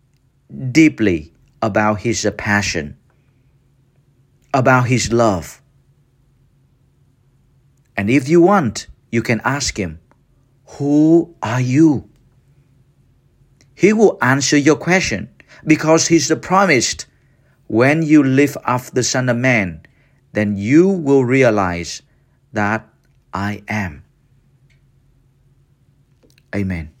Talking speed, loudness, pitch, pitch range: 95 wpm, -16 LUFS, 135 Hz, 115-140 Hz